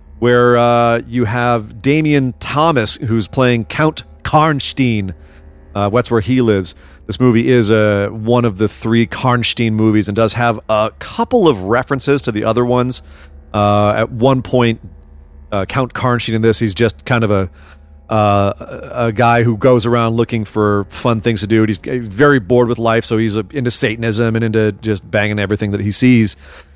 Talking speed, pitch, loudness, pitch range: 180 wpm, 115 Hz, -14 LUFS, 105-120 Hz